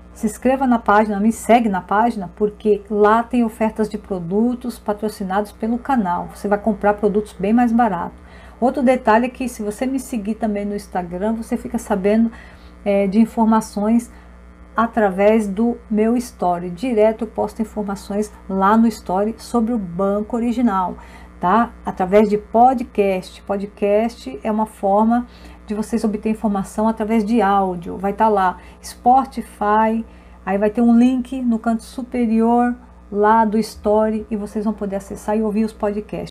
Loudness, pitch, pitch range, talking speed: -19 LUFS, 215 Hz, 205-230 Hz, 160 wpm